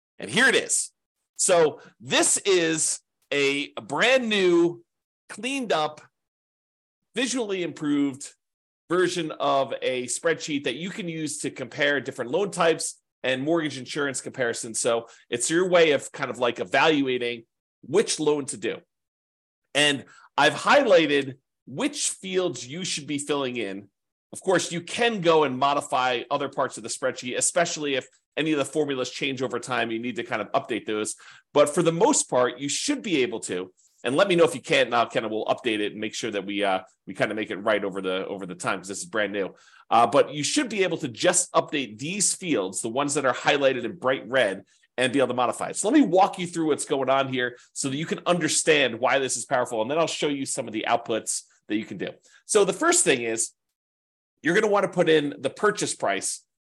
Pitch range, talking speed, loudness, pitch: 125-175 Hz, 210 wpm, -24 LUFS, 145 Hz